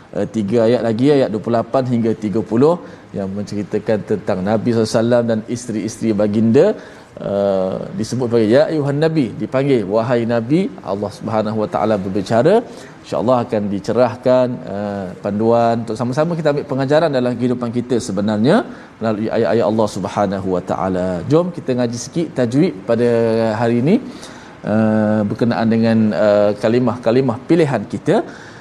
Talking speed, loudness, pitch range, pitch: 140 wpm, -17 LUFS, 105-125 Hz, 115 Hz